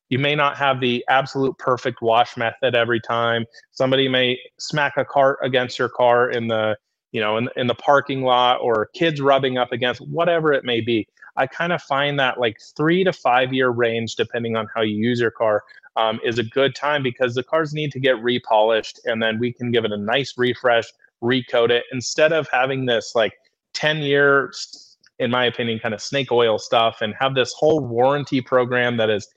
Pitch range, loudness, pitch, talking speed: 115-135 Hz, -20 LUFS, 125 Hz, 205 wpm